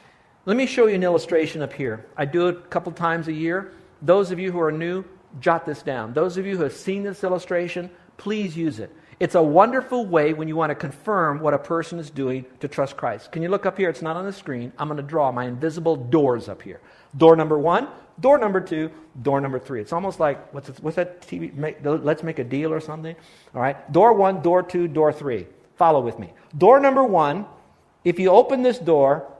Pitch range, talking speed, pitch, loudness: 145-185 Hz, 235 wpm, 165 Hz, -21 LUFS